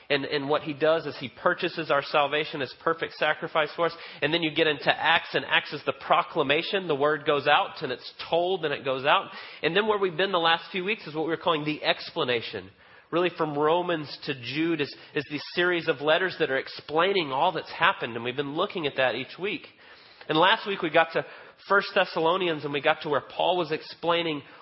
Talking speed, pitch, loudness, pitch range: 230 wpm, 160 Hz, -26 LUFS, 150-175 Hz